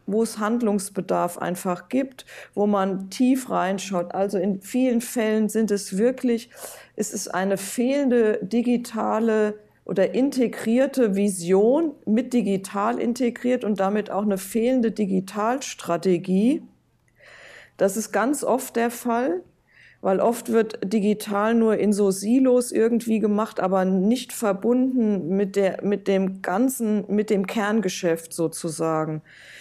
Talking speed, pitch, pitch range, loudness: 125 wpm, 215 Hz, 195-235 Hz, -23 LUFS